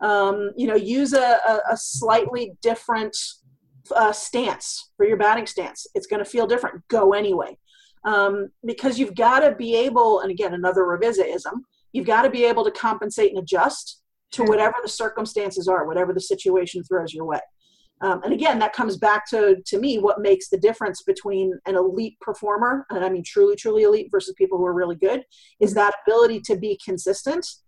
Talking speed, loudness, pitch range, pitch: 190 wpm, -21 LUFS, 195-255 Hz, 215 Hz